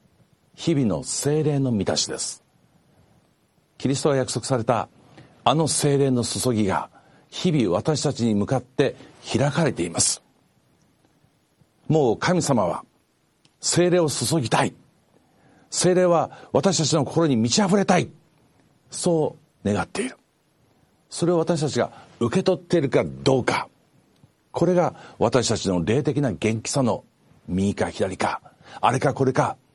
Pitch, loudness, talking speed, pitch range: 140 Hz, -22 LUFS, 245 characters per minute, 115-160 Hz